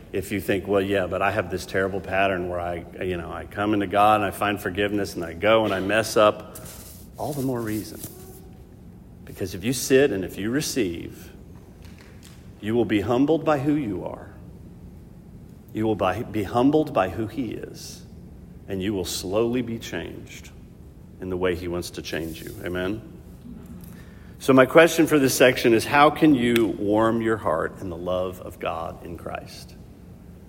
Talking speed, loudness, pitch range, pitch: 185 wpm, -23 LUFS, 90-115 Hz, 100 Hz